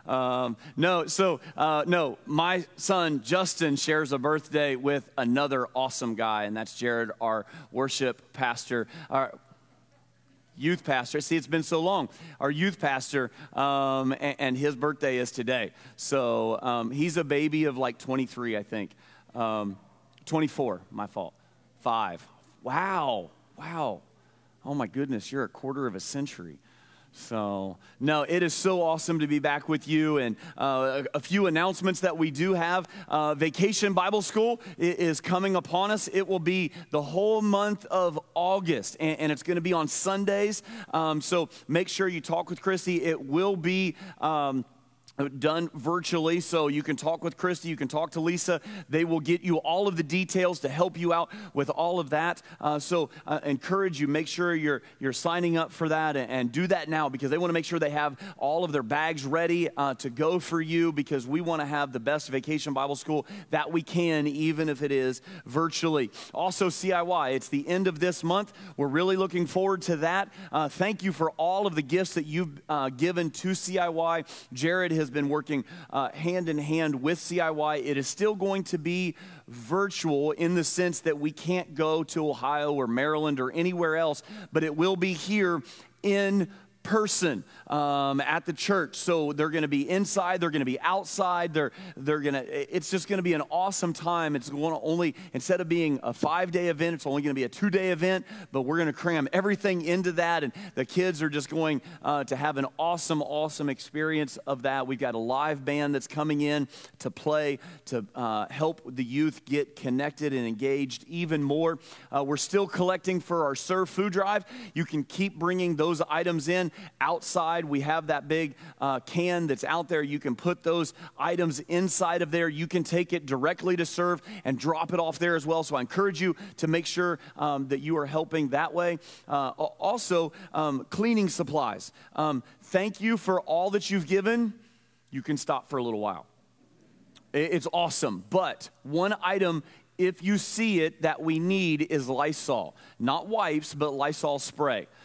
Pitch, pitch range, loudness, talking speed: 160 Hz, 145-180 Hz, -28 LUFS, 190 wpm